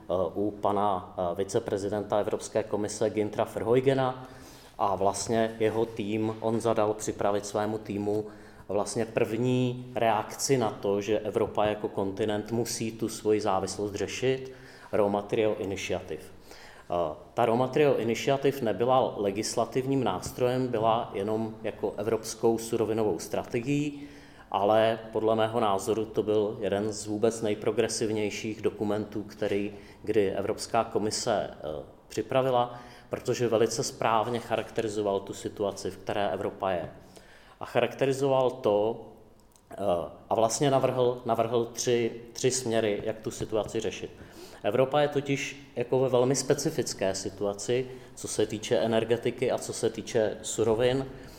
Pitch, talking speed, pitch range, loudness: 110 Hz, 120 wpm, 105-125 Hz, -29 LUFS